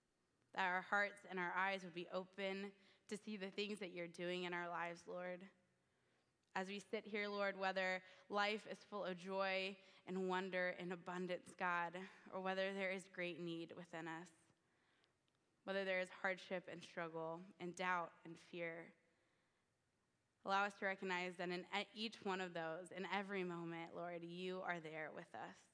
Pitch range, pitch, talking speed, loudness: 175-195 Hz, 185 Hz, 170 wpm, -46 LUFS